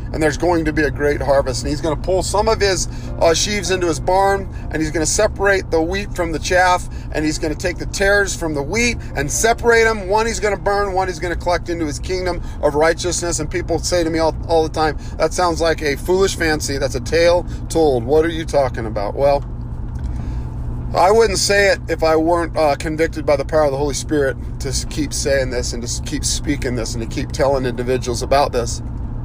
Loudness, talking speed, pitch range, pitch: -18 LUFS, 240 wpm, 140-175 Hz, 155 Hz